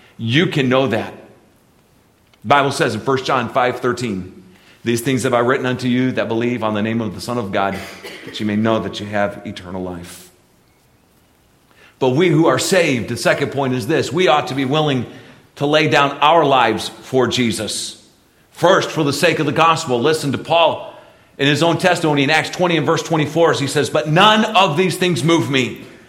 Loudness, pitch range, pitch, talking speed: -16 LUFS, 115-155 Hz, 130 Hz, 205 wpm